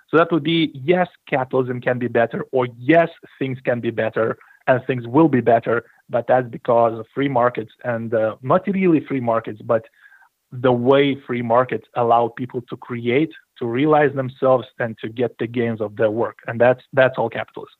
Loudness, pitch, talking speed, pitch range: -20 LUFS, 125 Hz, 190 wpm, 120-140 Hz